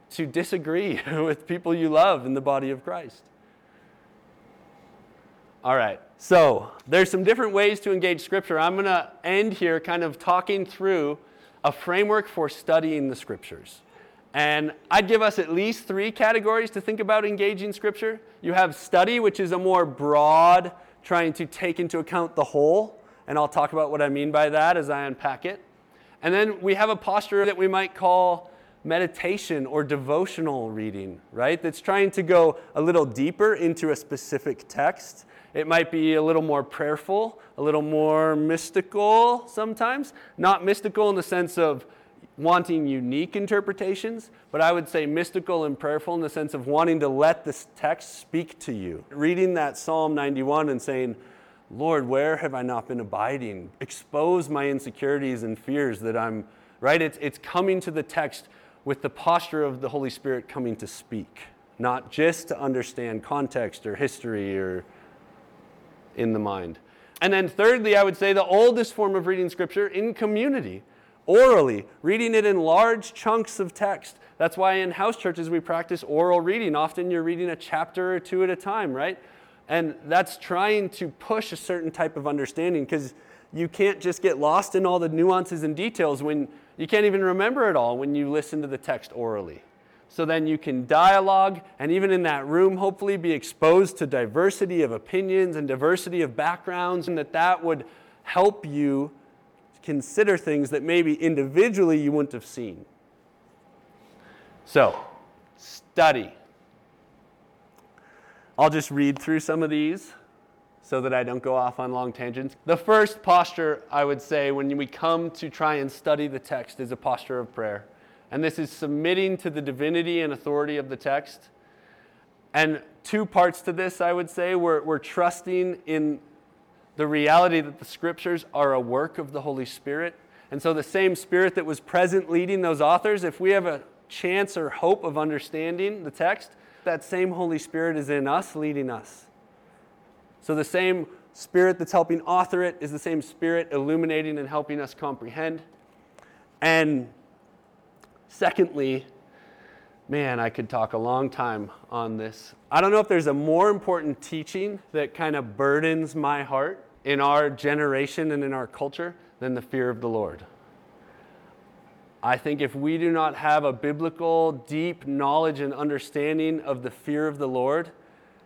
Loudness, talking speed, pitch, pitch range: -24 LUFS, 170 wpm, 160 Hz, 145-185 Hz